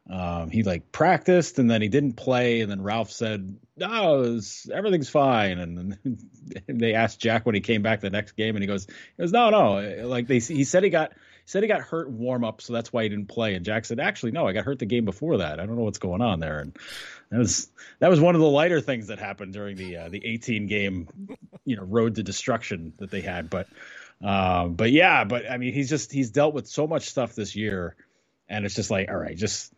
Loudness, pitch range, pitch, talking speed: -24 LUFS, 100-130 Hz, 115 Hz, 250 wpm